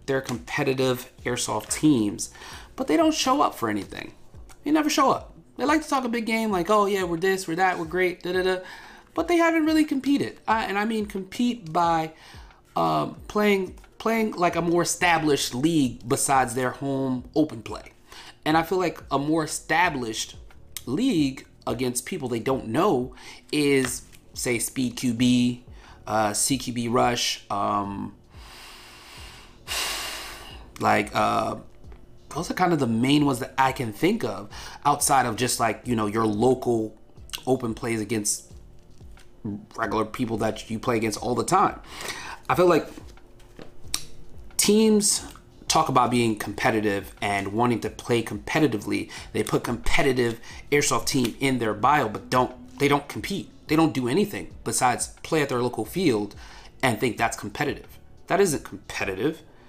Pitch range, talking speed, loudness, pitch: 115-170 Hz, 155 wpm, -24 LUFS, 130 Hz